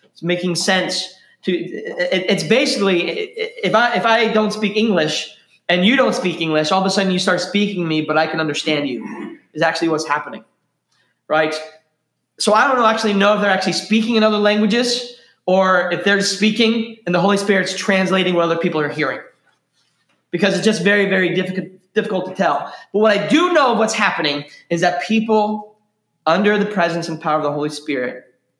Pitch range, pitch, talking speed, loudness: 170-215 Hz, 190 Hz, 190 wpm, -17 LUFS